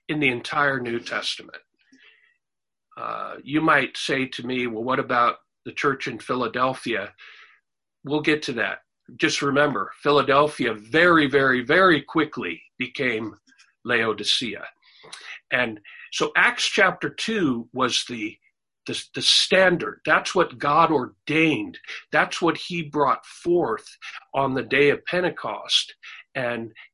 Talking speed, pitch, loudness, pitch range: 125 wpm, 145 Hz, -22 LUFS, 130-185 Hz